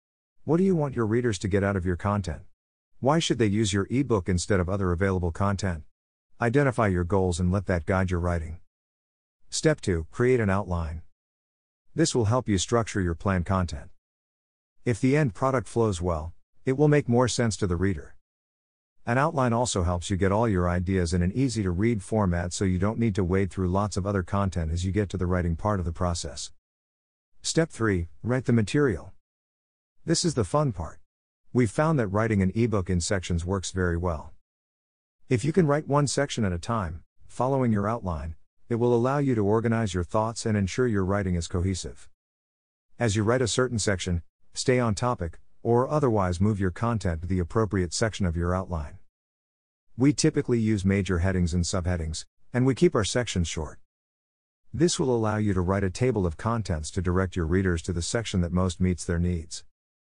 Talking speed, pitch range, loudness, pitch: 200 wpm, 85-115 Hz, -26 LUFS, 95 Hz